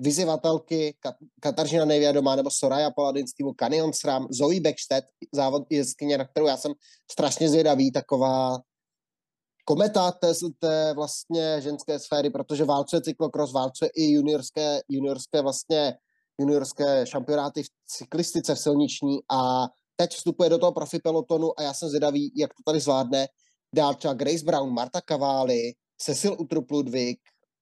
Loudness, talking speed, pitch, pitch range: -25 LUFS, 140 wpm, 150 Hz, 140-160 Hz